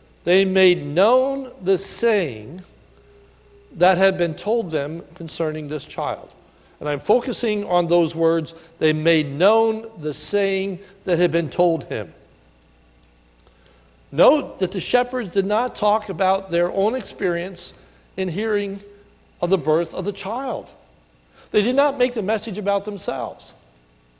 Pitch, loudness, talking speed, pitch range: 185 Hz, -21 LUFS, 140 wpm, 155-205 Hz